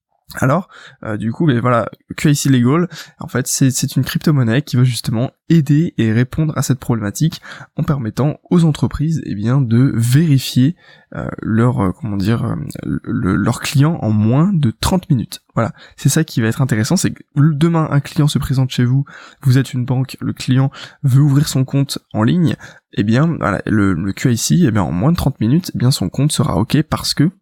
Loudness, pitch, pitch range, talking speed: -16 LUFS, 135 Hz, 120-150 Hz, 205 wpm